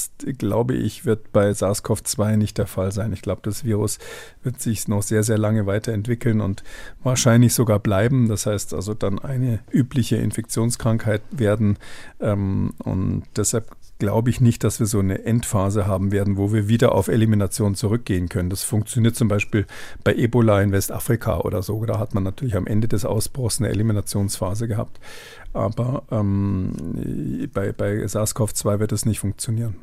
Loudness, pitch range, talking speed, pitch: -22 LUFS, 100-115 Hz, 165 wpm, 105 Hz